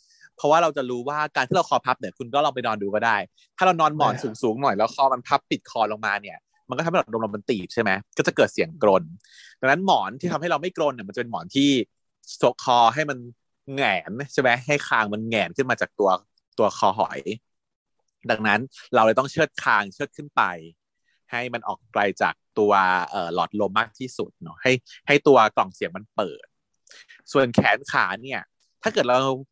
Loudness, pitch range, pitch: -23 LUFS, 115-145 Hz, 130 Hz